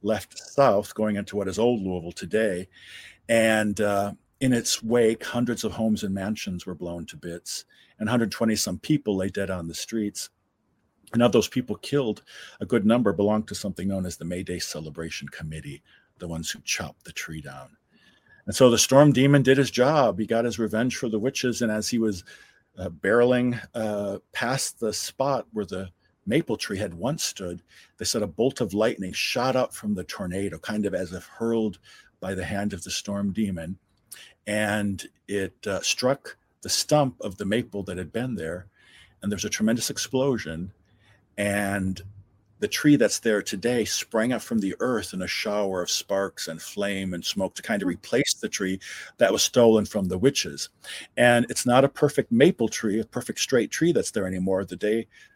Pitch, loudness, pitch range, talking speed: 105 Hz, -25 LUFS, 95-115 Hz, 195 wpm